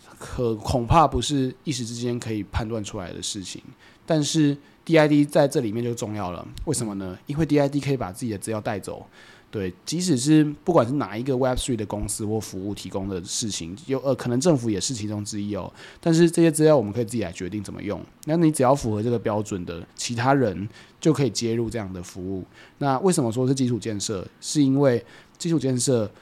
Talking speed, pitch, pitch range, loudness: 345 characters per minute, 120 Hz, 105-140 Hz, -24 LUFS